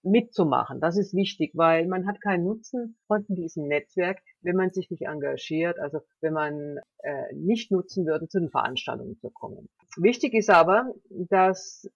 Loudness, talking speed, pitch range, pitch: -26 LUFS, 165 wpm, 165-205 Hz, 185 Hz